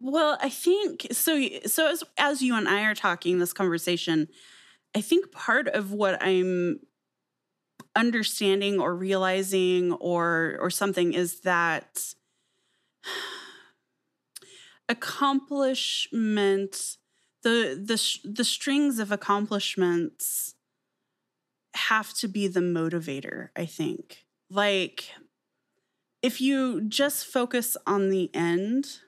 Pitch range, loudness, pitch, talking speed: 185-270 Hz, -26 LUFS, 210 Hz, 105 wpm